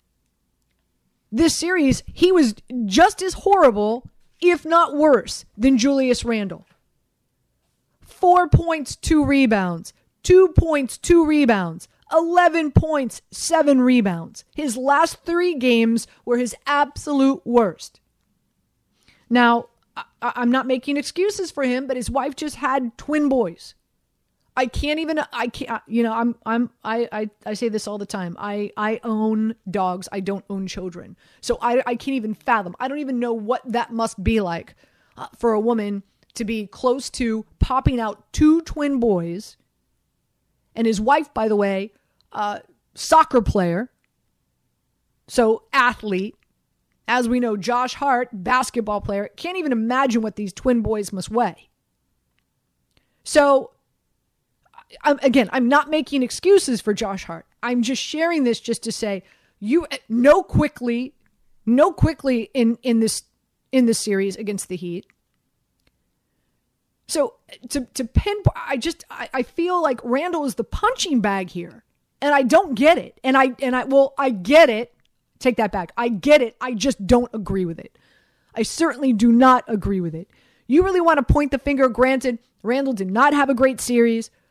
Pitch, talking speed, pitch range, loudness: 245 Hz, 160 wpm, 220-285 Hz, -20 LUFS